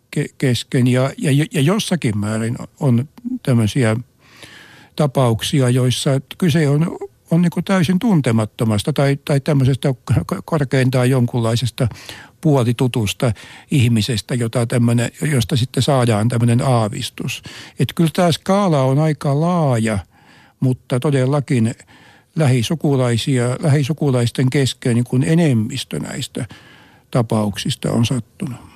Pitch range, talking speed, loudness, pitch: 120-150 Hz, 95 wpm, -18 LUFS, 130 Hz